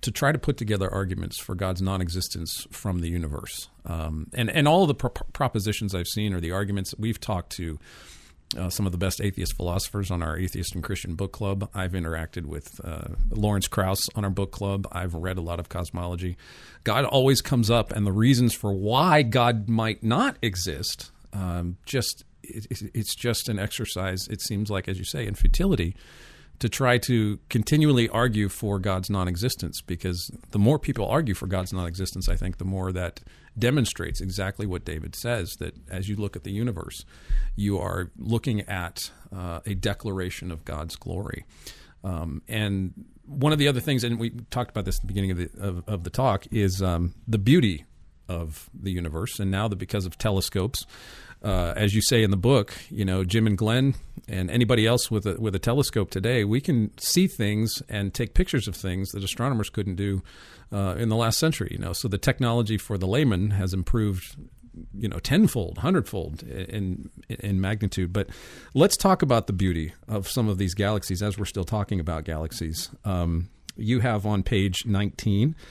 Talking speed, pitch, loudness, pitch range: 195 wpm, 100 Hz, -26 LUFS, 90-115 Hz